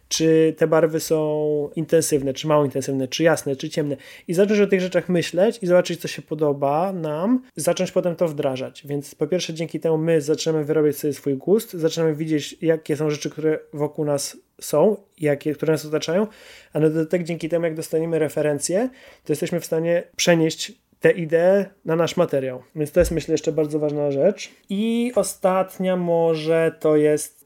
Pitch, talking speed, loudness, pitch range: 160 Hz, 180 wpm, -22 LUFS, 150-175 Hz